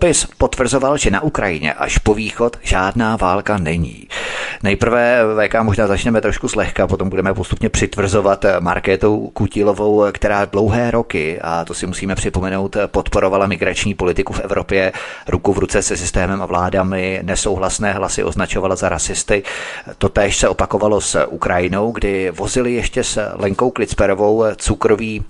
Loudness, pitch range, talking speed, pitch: -17 LUFS, 95-110 Hz, 140 wpm, 100 Hz